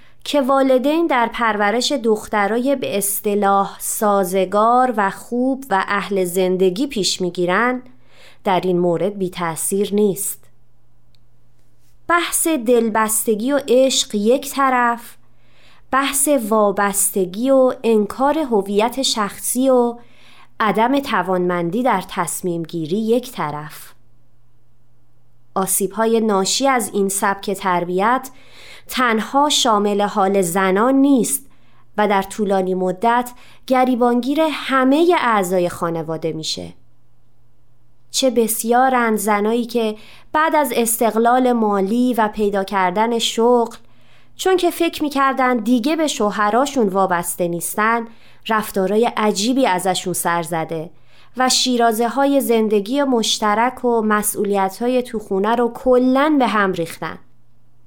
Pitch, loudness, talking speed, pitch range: 210 Hz, -17 LUFS, 105 wpm, 185-250 Hz